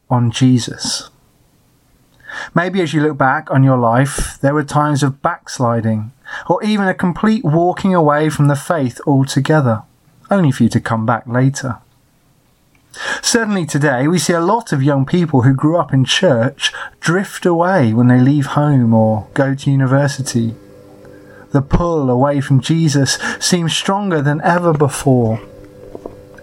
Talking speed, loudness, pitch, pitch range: 150 wpm, -15 LUFS, 140 Hz, 125-165 Hz